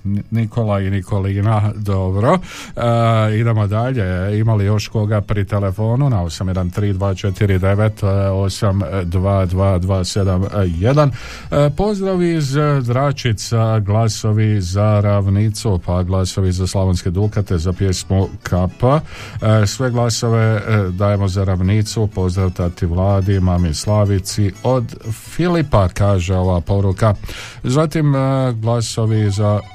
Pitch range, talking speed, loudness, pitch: 95-115 Hz, 100 wpm, -17 LUFS, 105 Hz